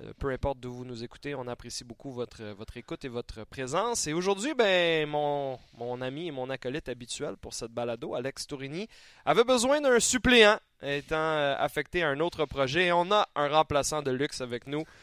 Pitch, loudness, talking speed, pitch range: 145 Hz, -28 LUFS, 195 wpm, 125-170 Hz